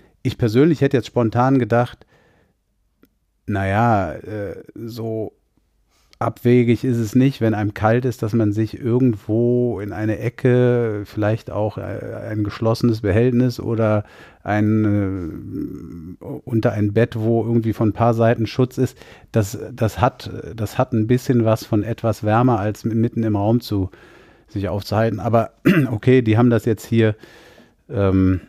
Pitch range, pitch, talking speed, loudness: 105-120 Hz, 115 Hz, 140 wpm, -19 LUFS